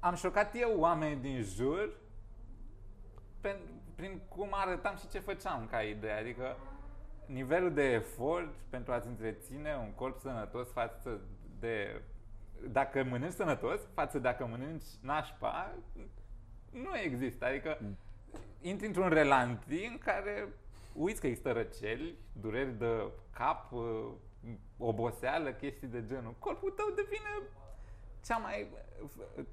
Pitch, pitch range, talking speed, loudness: 125 Hz, 110-155 Hz, 120 wpm, -37 LUFS